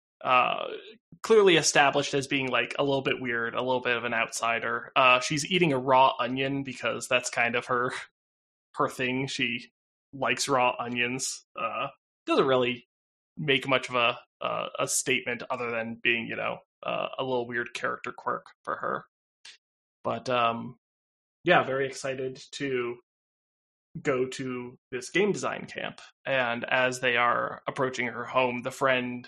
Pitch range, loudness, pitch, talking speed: 120-135 Hz, -27 LUFS, 125 Hz, 160 wpm